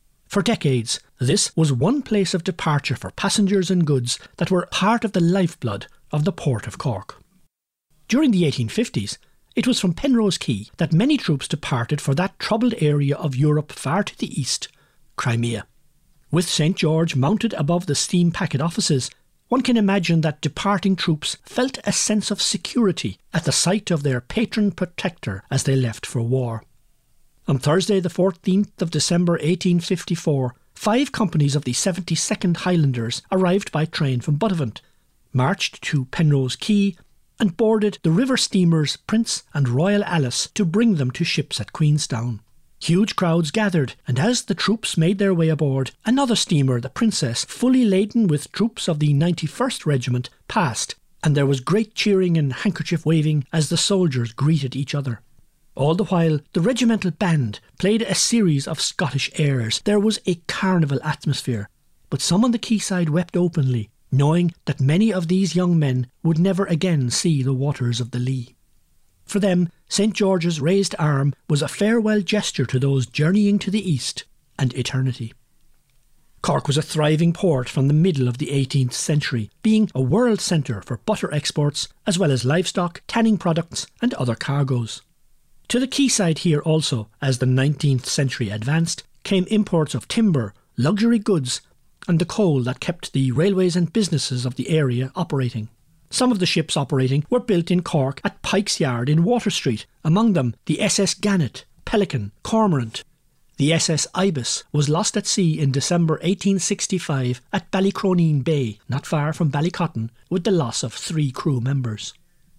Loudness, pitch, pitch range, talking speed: -21 LUFS, 160 Hz, 135-195 Hz, 170 wpm